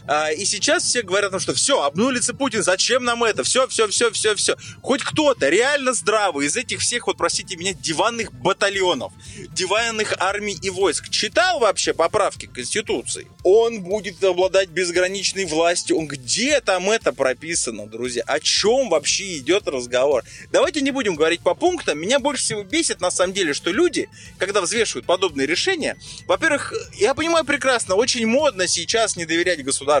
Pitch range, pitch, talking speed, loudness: 180-260 Hz, 200 Hz, 165 wpm, -20 LUFS